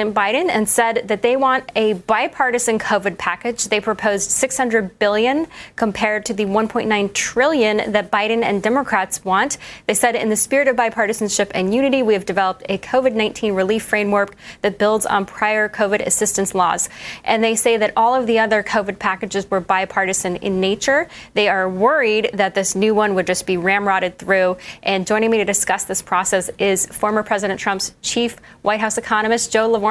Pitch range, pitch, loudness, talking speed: 195-225 Hz, 215 Hz, -18 LUFS, 185 wpm